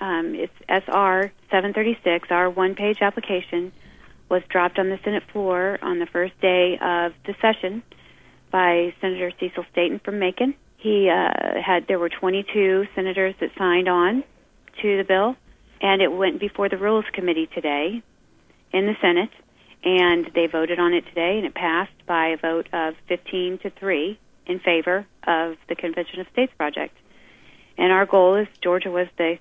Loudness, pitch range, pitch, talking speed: -22 LUFS, 175-195 Hz, 185 Hz, 165 wpm